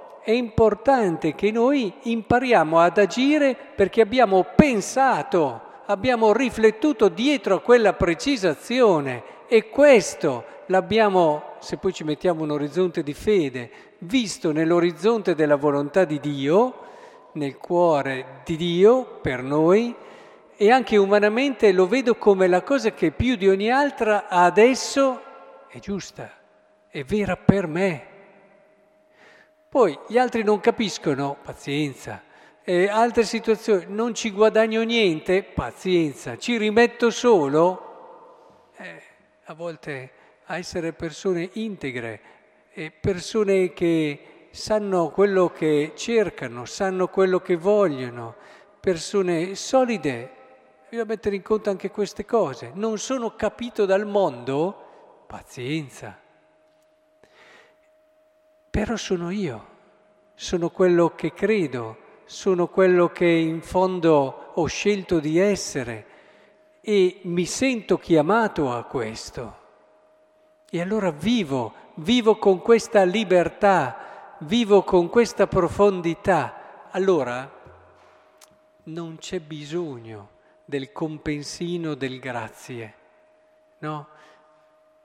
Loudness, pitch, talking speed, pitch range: -21 LUFS, 195 Hz, 105 wpm, 165-225 Hz